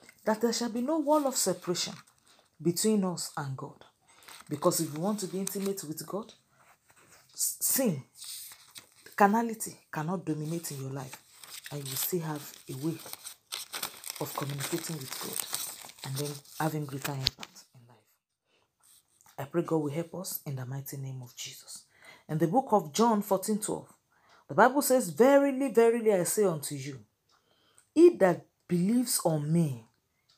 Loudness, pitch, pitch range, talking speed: -30 LUFS, 170 Hz, 145-210 Hz, 155 wpm